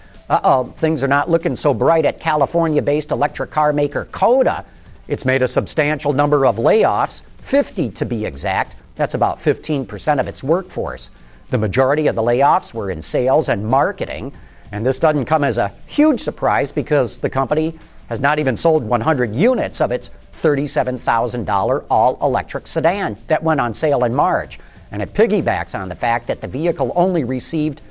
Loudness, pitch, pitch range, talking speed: -18 LUFS, 145 Hz, 125-155 Hz, 180 wpm